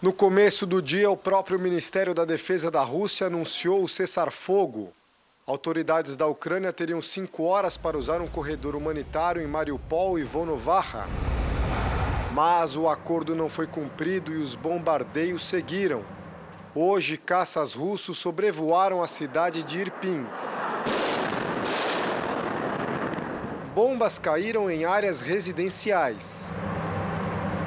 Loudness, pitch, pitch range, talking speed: -26 LUFS, 170 Hz, 160-190 Hz, 115 wpm